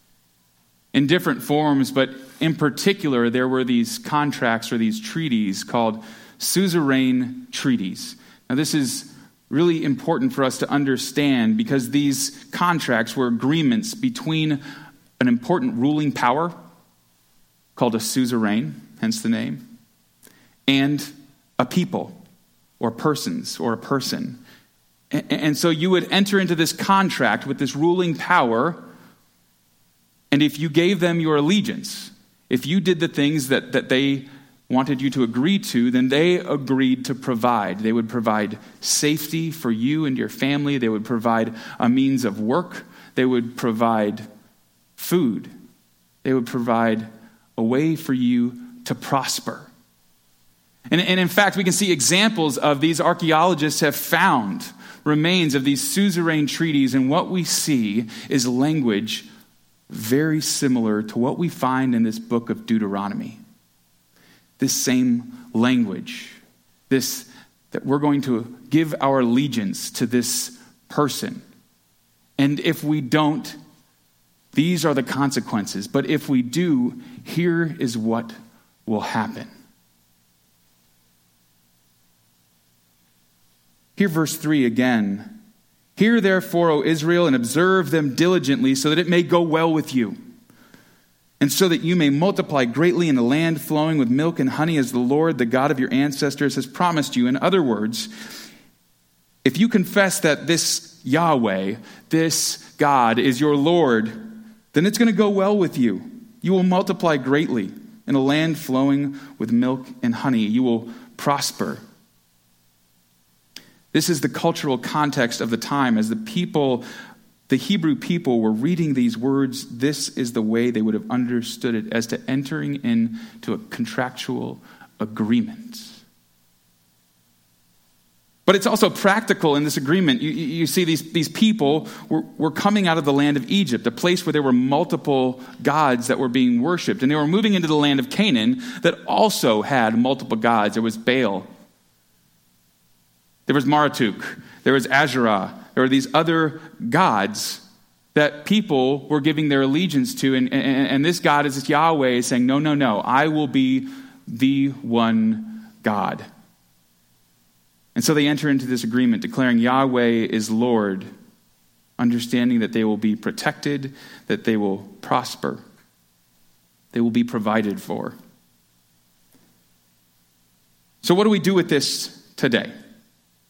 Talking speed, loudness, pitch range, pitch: 145 wpm, -20 LUFS, 115-175 Hz, 140 Hz